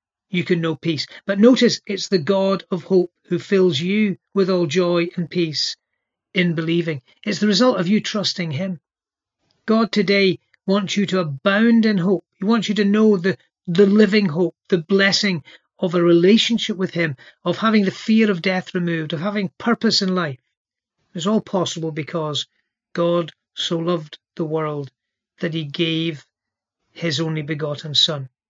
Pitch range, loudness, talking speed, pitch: 165-200 Hz, -19 LUFS, 170 wpm, 180 Hz